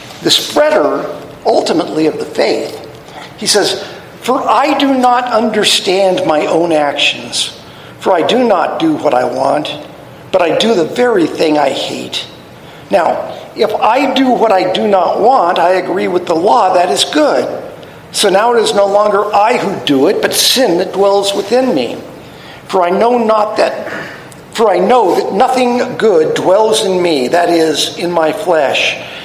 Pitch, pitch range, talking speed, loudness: 215 Hz, 185-255 Hz, 170 wpm, -11 LUFS